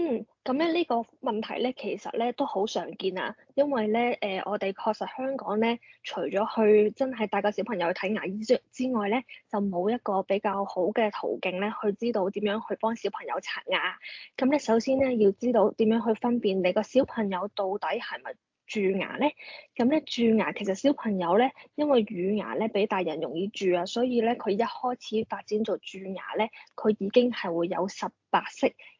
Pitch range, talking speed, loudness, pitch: 195-245 Hz, 290 characters per minute, -28 LUFS, 215 Hz